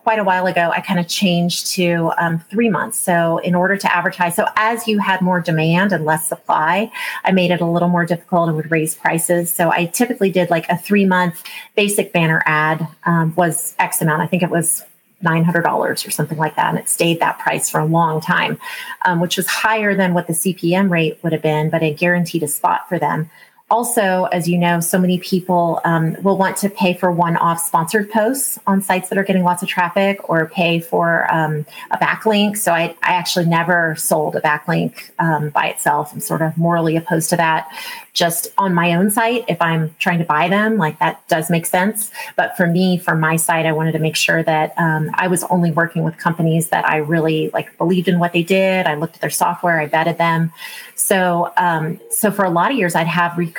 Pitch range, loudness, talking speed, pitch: 165-190 Hz, -17 LUFS, 225 wpm, 175 Hz